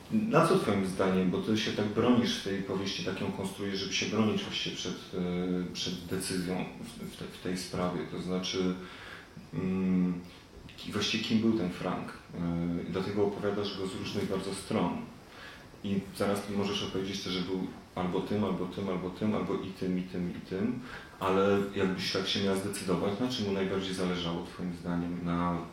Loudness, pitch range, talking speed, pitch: -32 LUFS, 90-100 Hz, 190 wpm, 95 Hz